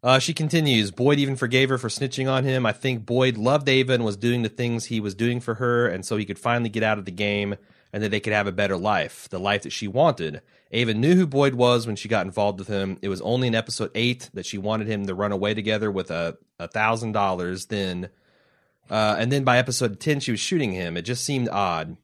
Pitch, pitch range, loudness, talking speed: 110 Hz, 100-125 Hz, -23 LUFS, 255 wpm